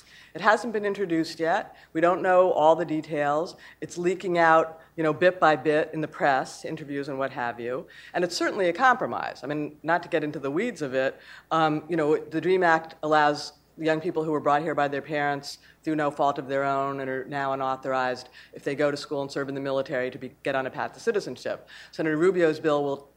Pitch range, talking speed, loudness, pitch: 140-165 Hz, 235 wpm, -26 LUFS, 155 Hz